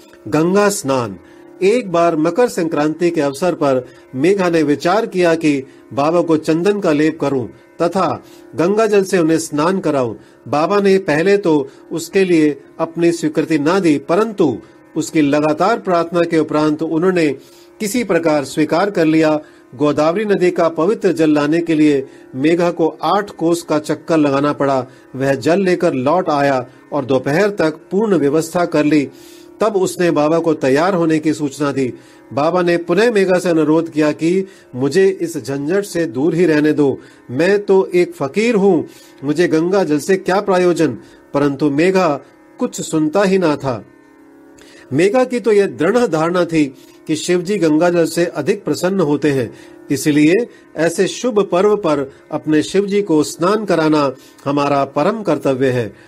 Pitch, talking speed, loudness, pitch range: 165 Hz, 160 wpm, -16 LUFS, 150-185 Hz